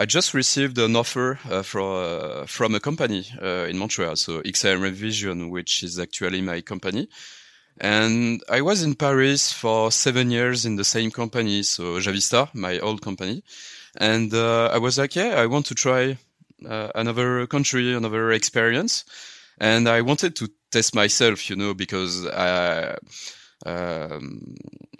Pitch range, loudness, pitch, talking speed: 100-125 Hz, -22 LUFS, 115 Hz, 155 wpm